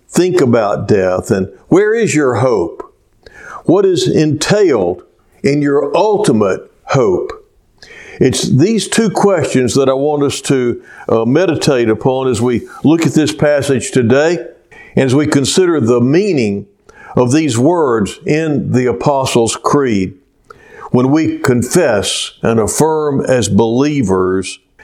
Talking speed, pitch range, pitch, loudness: 130 wpm, 120-155 Hz, 140 Hz, -13 LUFS